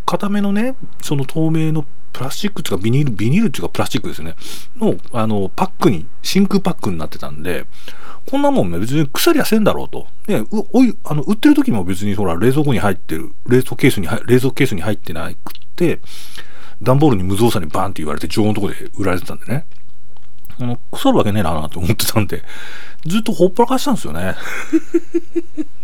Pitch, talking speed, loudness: 125 Hz, 415 characters per minute, -18 LUFS